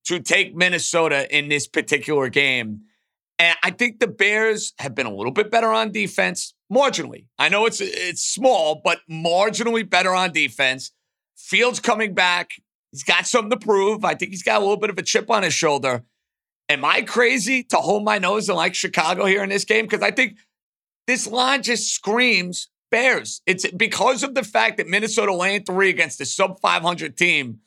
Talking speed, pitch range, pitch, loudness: 190 wpm, 170-220 Hz, 195 Hz, -19 LUFS